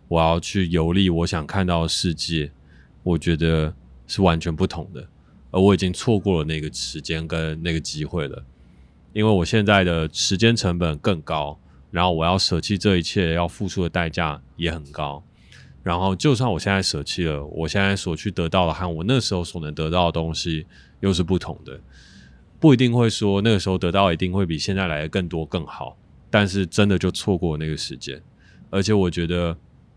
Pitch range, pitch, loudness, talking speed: 80-95 Hz, 85 Hz, -22 LUFS, 285 characters per minute